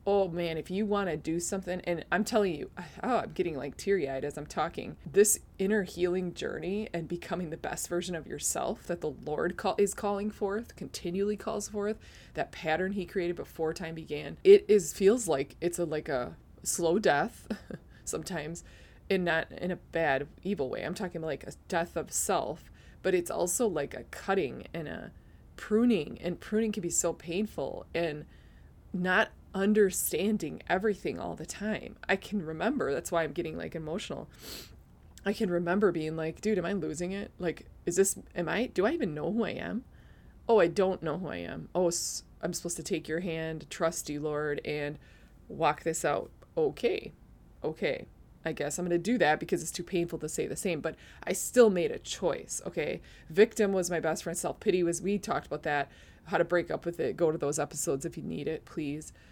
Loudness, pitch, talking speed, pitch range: -31 LUFS, 175 Hz, 200 wpm, 160-205 Hz